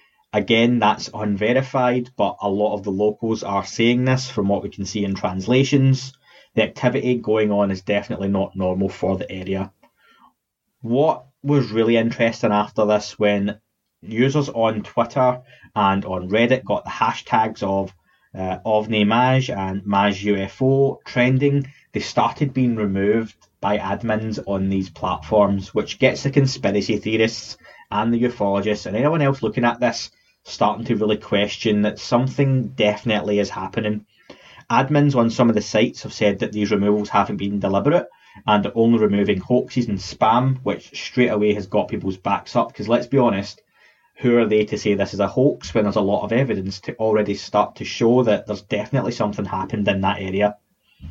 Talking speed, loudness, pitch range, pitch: 175 wpm, -20 LUFS, 100-120 Hz, 105 Hz